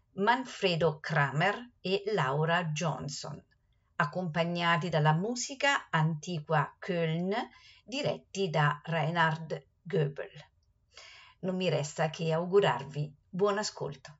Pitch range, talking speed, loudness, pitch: 155-190 Hz, 90 wpm, -31 LUFS, 165 Hz